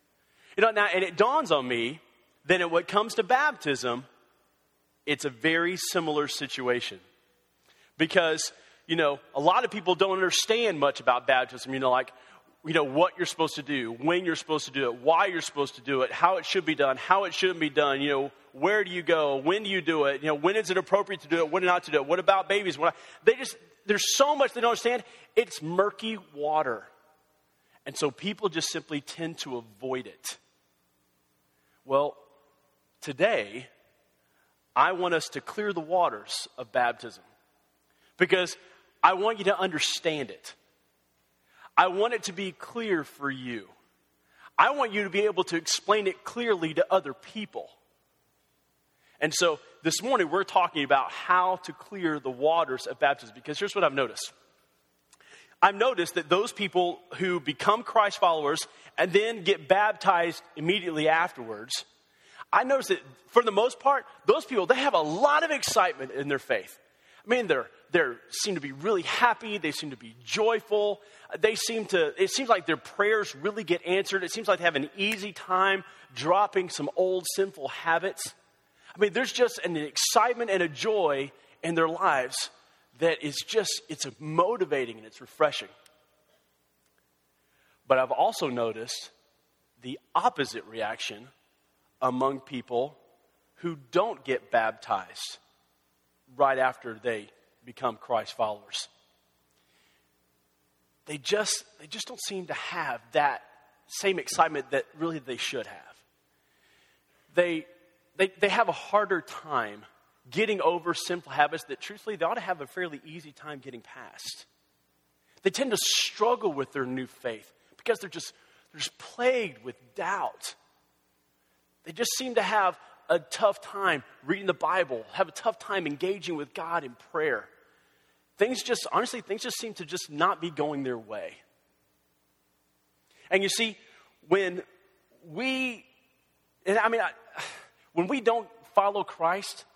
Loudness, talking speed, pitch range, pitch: -27 LUFS, 165 wpm, 135-200 Hz, 165 Hz